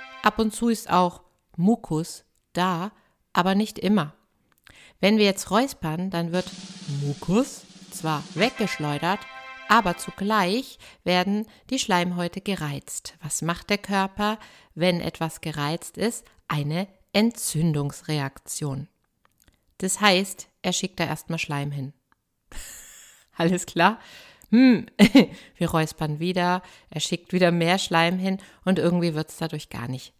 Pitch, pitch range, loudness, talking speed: 180 Hz, 160-200 Hz, -24 LUFS, 125 wpm